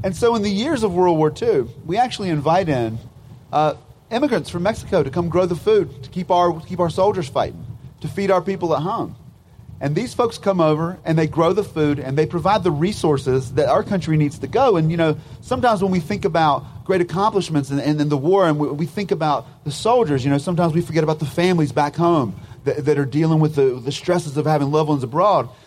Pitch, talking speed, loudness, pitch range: 160 Hz, 240 wpm, -19 LUFS, 145-185 Hz